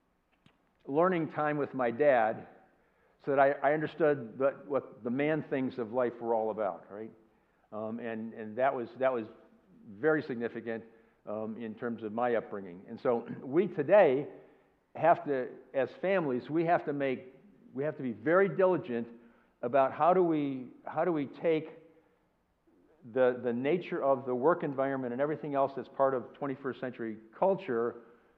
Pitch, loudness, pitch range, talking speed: 135 Hz, -31 LUFS, 115-155 Hz, 165 wpm